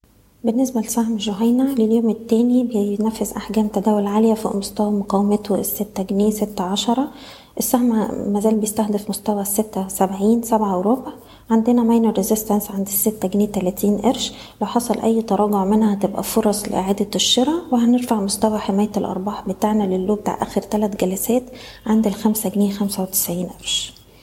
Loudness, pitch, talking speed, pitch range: -19 LUFS, 215 Hz, 140 wpm, 200-230 Hz